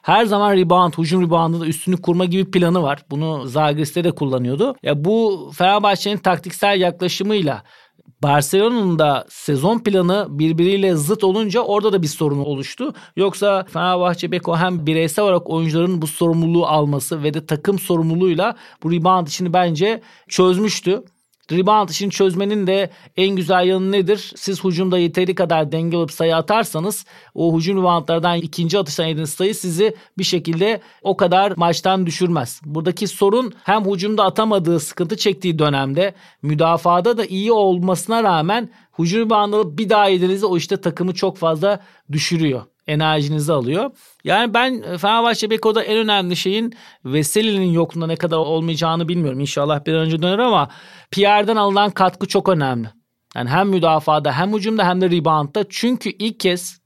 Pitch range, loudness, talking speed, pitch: 165-200 Hz, -18 LUFS, 150 wpm, 180 Hz